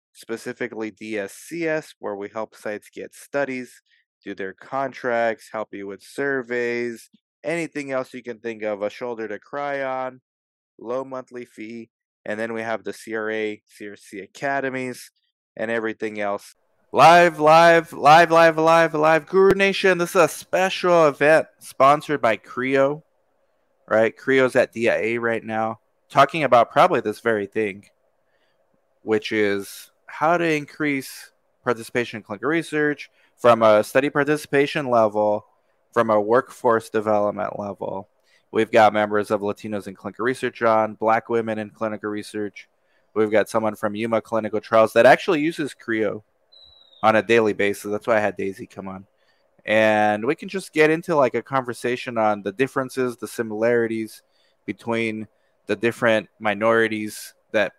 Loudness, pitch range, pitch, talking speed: -21 LUFS, 105-135 Hz, 115 Hz, 145 wpm